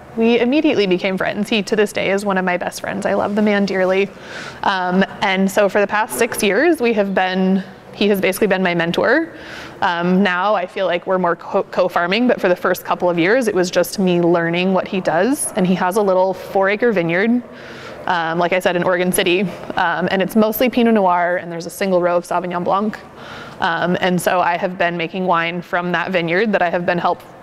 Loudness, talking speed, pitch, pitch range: -17 LUFS, 230 wpm, 185 Hz, 175-205 Hz